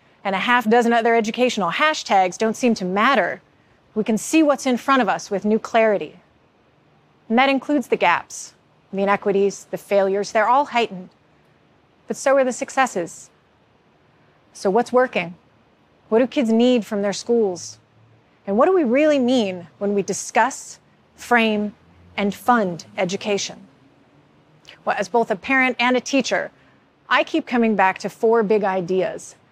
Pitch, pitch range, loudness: 225 Hz, 195-250 Hz, -19 LUFS